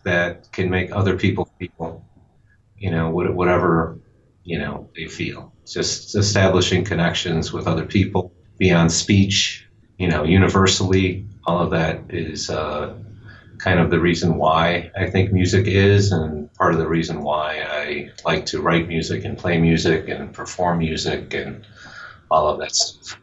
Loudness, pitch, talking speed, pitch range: -20 LUFS, 90 Hz, 155 wpm, 85-100 Hz